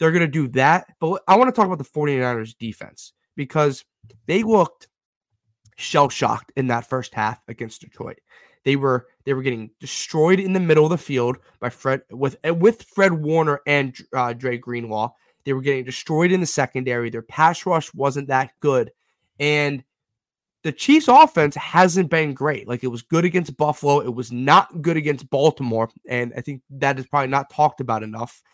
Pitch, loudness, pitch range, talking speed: 140 Hz, -20 LUFS, 125-160 Hz, 185 wpm